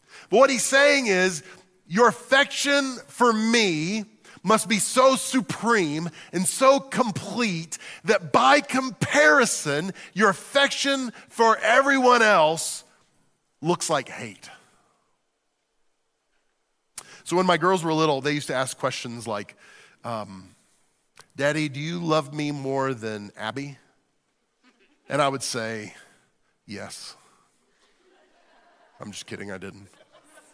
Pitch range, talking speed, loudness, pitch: 145-240 Hz, 115 wpm, -22 LUFS, 175 Hz